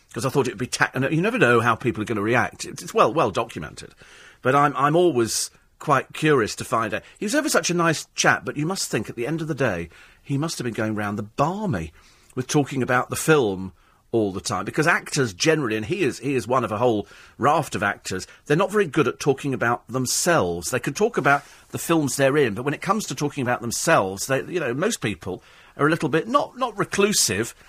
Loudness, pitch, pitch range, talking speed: -22 LUFS, 135 Hz, 115-160 Hz, 245 wpm